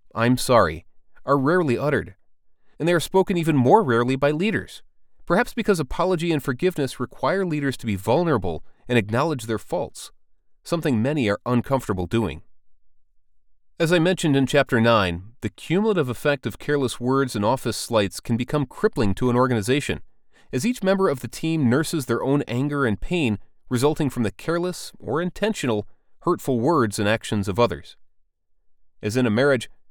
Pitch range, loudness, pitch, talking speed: 110-155 Hz, -22 LUFS, 125 Hz, 165 wpm